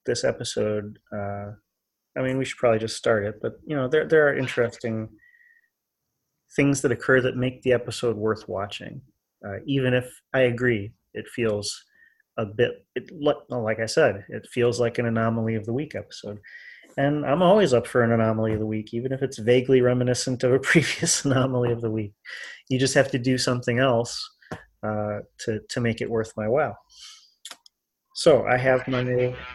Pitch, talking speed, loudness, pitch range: 125 Hz, 190 wpm, -24 LUFS, 110-130 Hz